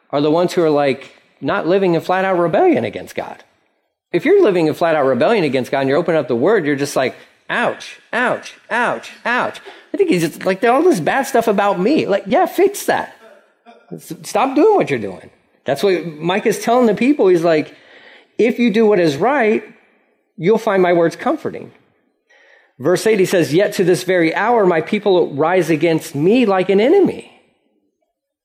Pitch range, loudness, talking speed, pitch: 165-235 Hz, -16 LUFS, 200 wpm, 185 Hz